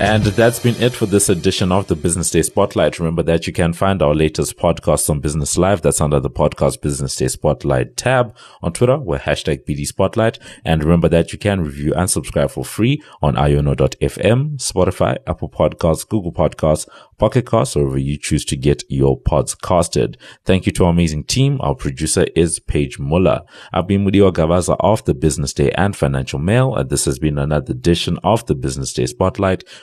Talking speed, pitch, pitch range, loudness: 195 wpm, 85 Hz, 75-100 Hz, -17 LUFS